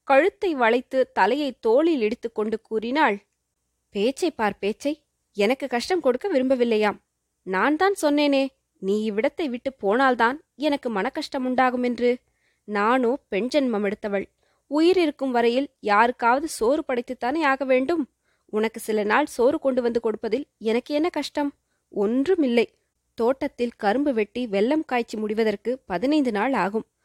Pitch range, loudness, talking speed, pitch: 220-285 Hz, -23 LUFS, 125 wpm, 245 Hz